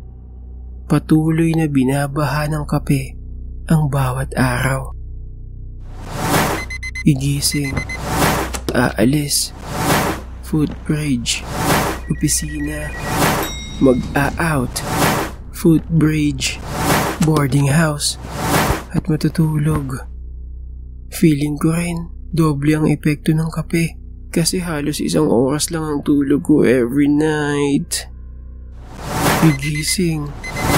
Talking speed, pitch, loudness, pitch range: 75 wpm, 145 Hz, -17 LUFS, 125-155 Hz